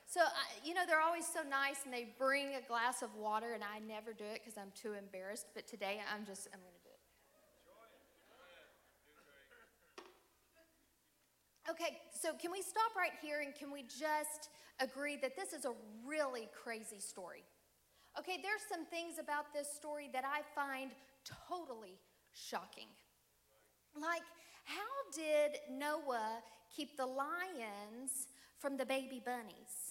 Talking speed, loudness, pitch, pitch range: 150 wpm, -42 LUFS, 275 Hz, 230-315 Hz